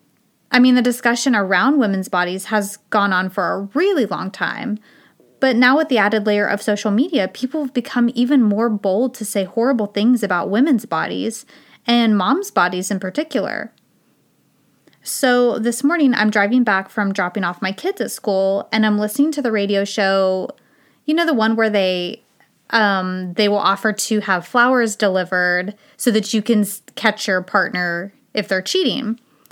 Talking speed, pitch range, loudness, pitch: 175 wpm, 195-250 Hz, -18 LUFS, 215 Hz